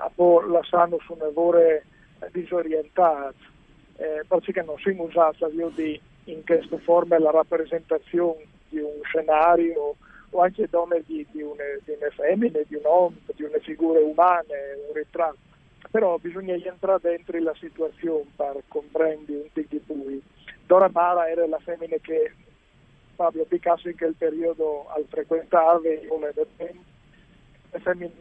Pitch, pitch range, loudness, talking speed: 165 Hz, 155-175 Hz, -24 LUFS, 130 wpm